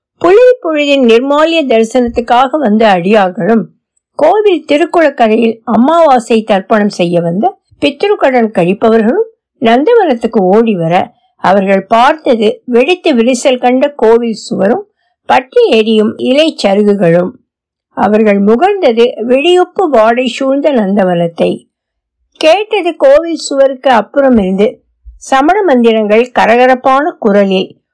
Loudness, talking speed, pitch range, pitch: -9 LUFS, 85 wpm, 220-305 Hz, 245 Hz